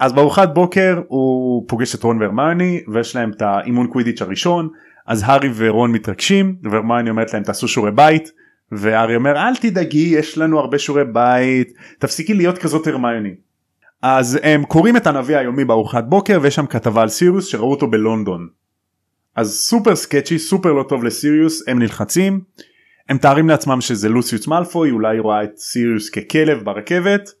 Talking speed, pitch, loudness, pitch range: 160 wpm, 135 Hz, -16 LUFS, 115-160 Hz